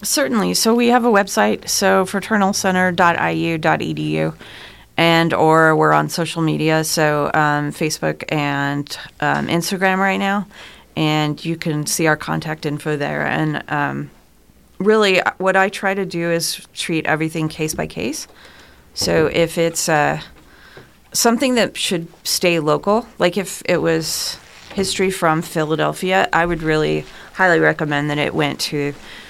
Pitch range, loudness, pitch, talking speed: 150-190 Hz, -18 LUFS, 165 Hz, 140 wpm